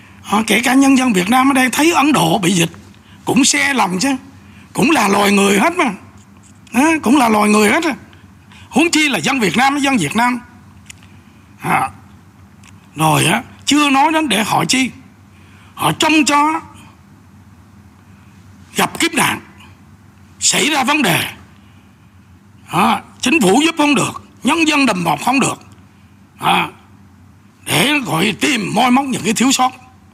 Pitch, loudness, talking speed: 180 Hz, -14 LUFS, 150 wpm